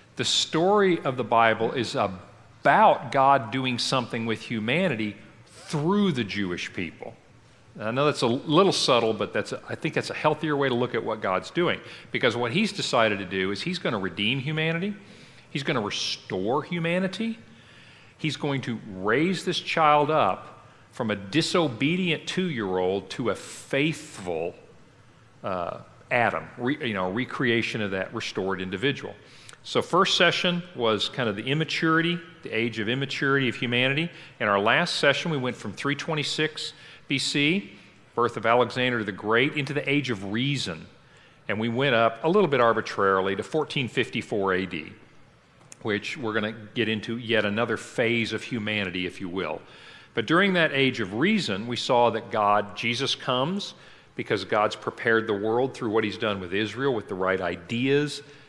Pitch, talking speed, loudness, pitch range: 125 Hz, 170 wpm, -25 LUFS, 110-150 Hz